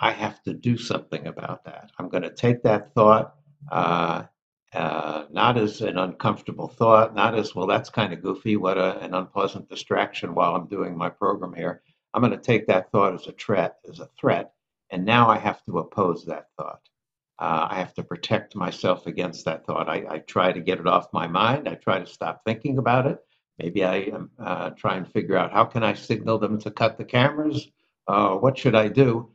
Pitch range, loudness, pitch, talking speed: 95-120 Hz, -24 LUFS, 110 Hz, 215 wpm